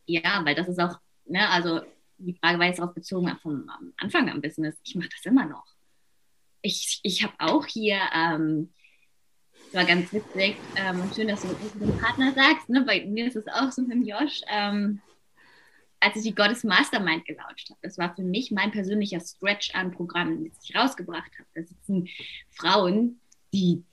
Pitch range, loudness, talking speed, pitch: 175-215 Hz, -25 LUFS, 190 wpm, 190 Hz